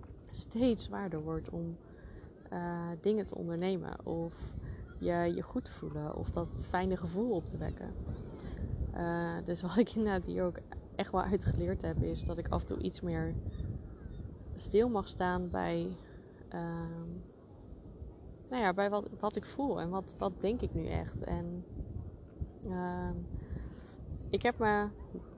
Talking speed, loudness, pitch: 150 wpm, -37 LUFS, 170 Hz